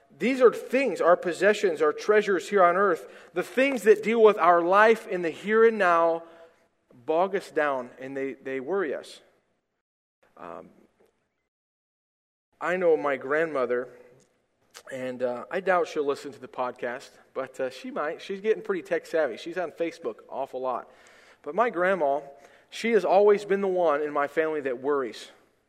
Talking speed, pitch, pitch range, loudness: 170 wpm, 180 Hz, 150-220 Hz, -25 LUFS